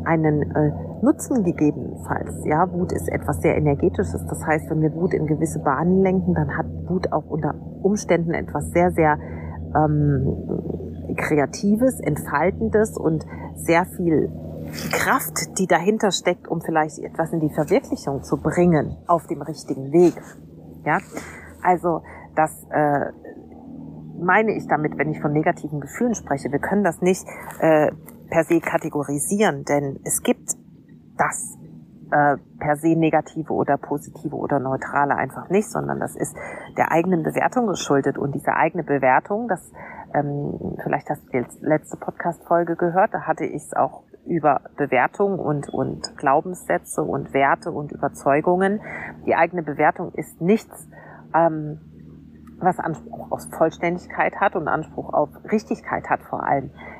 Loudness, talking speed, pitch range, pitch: -22 LUFS, 145 wpm, 145-175 Hz, 160 Hz